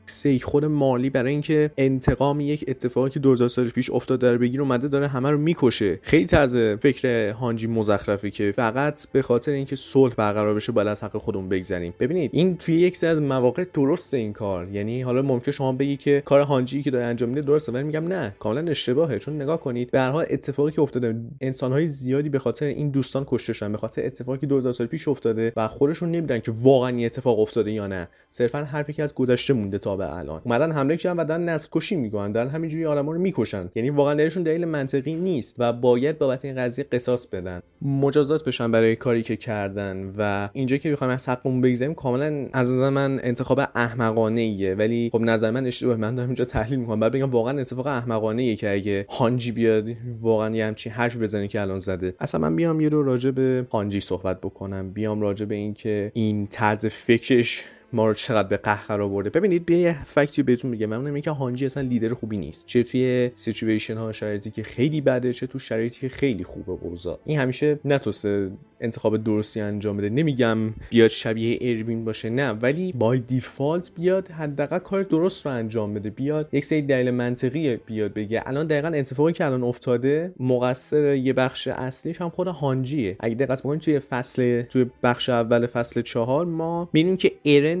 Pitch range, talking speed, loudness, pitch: 110-145 Hz, 200 wpm, -23 LUFS, 125 Hz